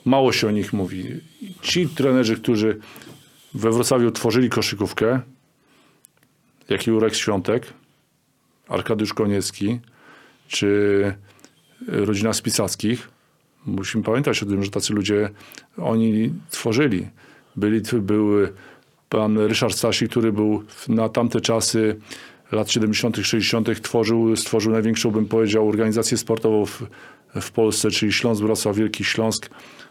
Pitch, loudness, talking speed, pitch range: 110 Hz, -21 LUFS, 110 wpm, 105-120 Hz